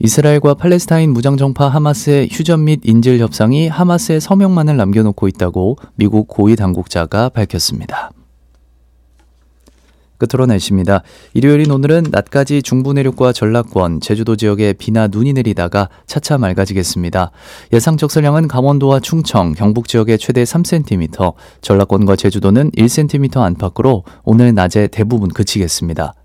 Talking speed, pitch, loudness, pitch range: 345 characters per minute, 115 Hz, -13 LUFS, 95-140 Hz